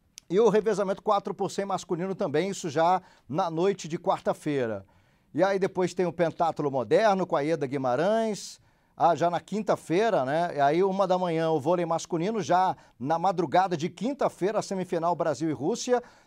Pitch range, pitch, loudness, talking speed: 165-195 Hz, 180 Hz, -27 LUFS, 170 wpm